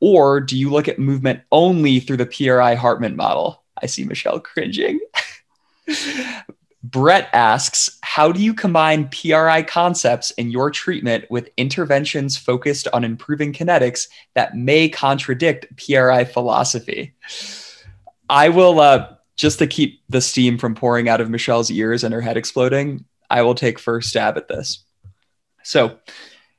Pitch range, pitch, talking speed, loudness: 120-155 Hz, 130 Hz, 145 wpm, -17 LUFS